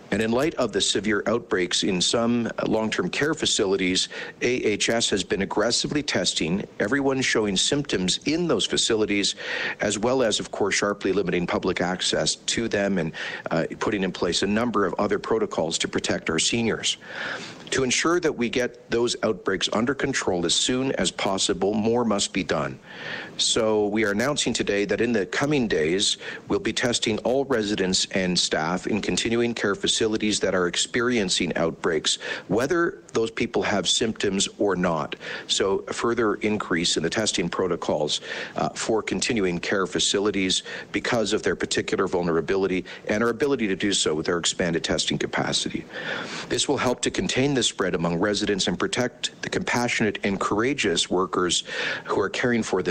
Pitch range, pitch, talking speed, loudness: 95-120 Hz, 105 Hz, 170 wpm, -24 LUFS